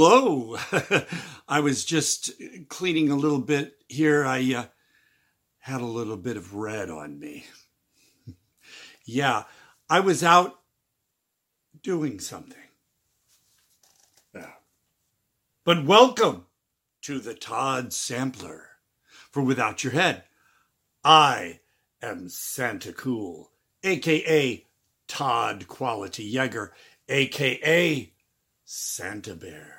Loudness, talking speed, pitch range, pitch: -24 LUFS, 95 wpm, 115-155 Hz, 135 Hz